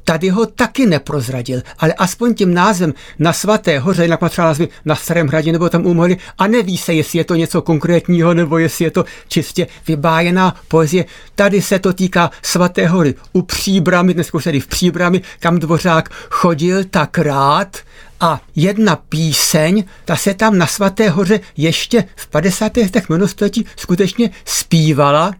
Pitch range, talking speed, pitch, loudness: 165-195 Hz, 160 wpm, 175 Hz, -14 LUFS